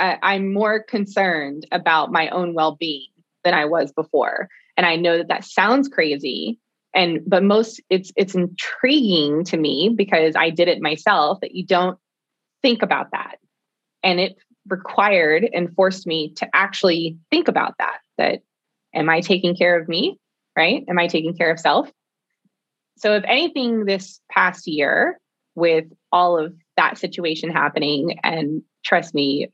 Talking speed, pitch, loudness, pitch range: 155 wpm, 180 Hz, -19 LUFS, 165-200 Hz